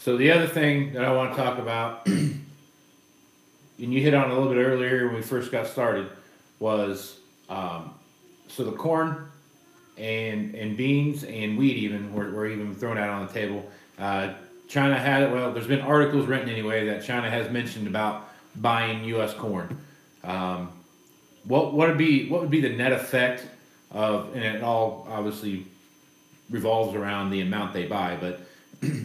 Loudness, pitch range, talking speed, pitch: -26 LUFS, 105-135 Hz, 175 wpm, 115 Hz